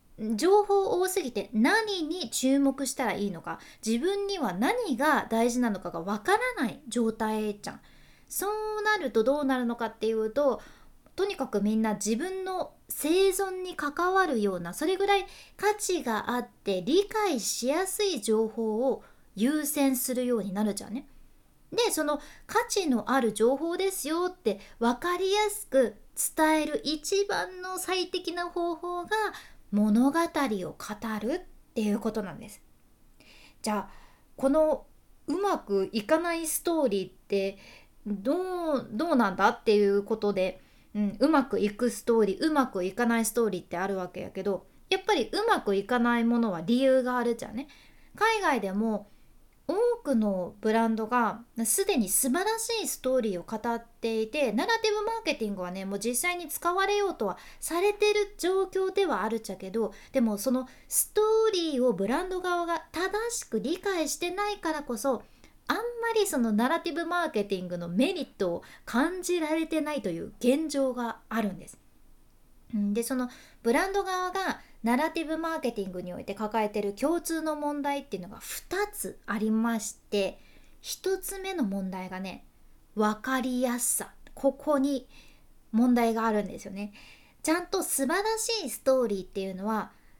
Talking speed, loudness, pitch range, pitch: 320 characters per minute, -28 LUFS, 220-355 Hz, 265 Hz